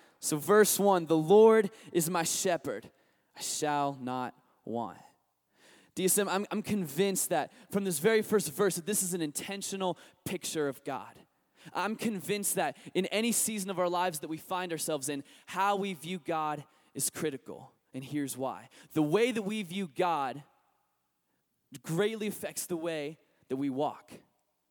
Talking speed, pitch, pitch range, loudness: 160 wpm, 180 Hz, 150-200 Hz, -31 LUFS